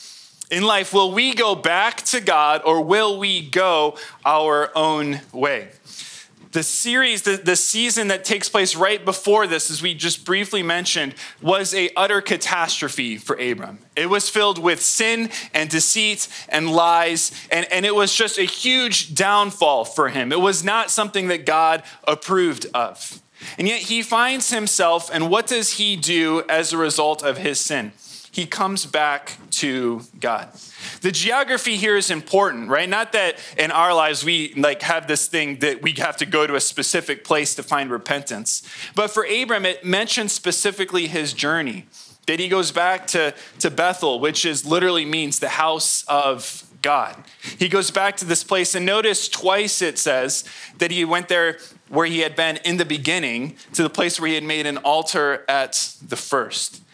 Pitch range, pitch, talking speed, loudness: 155-200 Hz, 175 Hz, 180 wpm, -19 LUFS